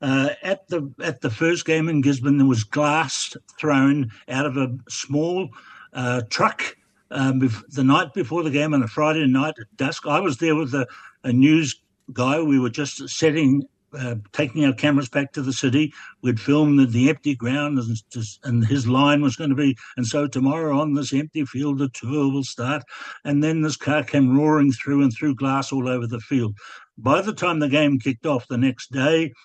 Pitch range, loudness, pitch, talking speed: 130-150 Hz, -21 LUFS, 140 Hz, 205 wpm